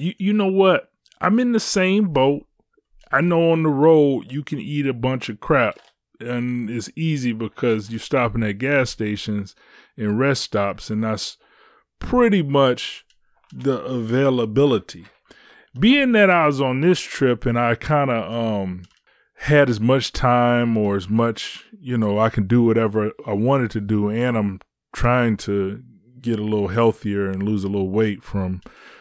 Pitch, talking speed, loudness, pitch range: 120 Hz, 170 wpm, -20 LUFS, 110-145 Hz